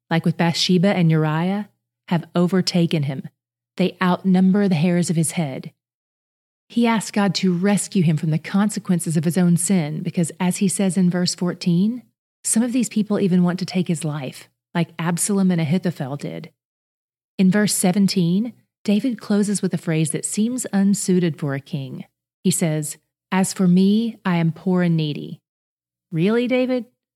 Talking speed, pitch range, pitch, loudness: 170 wpm, 165-200 Hz, 180 Hz, -20 LUFS